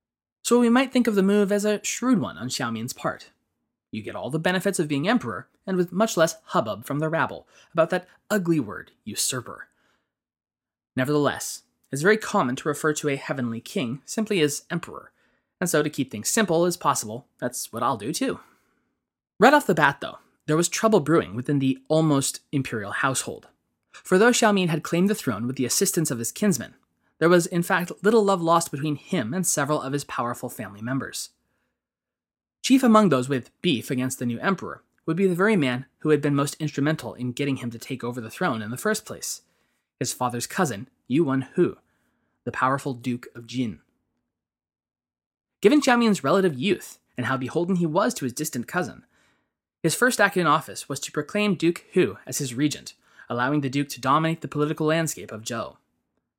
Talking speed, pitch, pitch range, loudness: 195 wpm, 150 Hz, 130-185 Hz, -24 LUFS